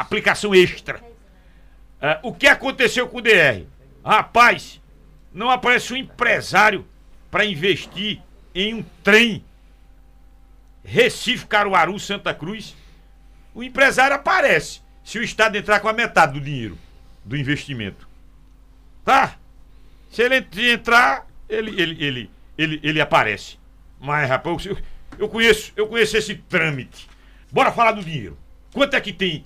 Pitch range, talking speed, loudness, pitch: 155-230 Hz, 130 wpm, -18 LUFS, 205 Hz